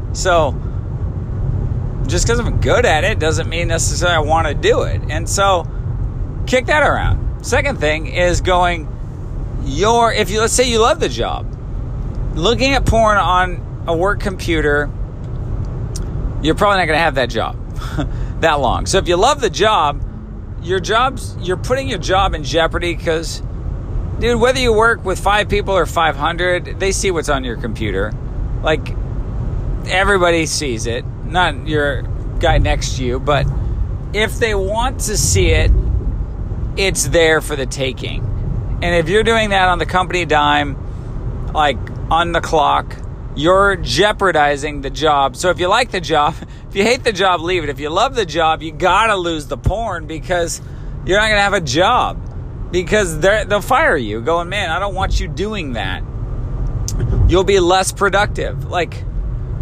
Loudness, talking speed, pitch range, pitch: -16 LUFS, 170 wpm, 115-180 Hz, 145 Hz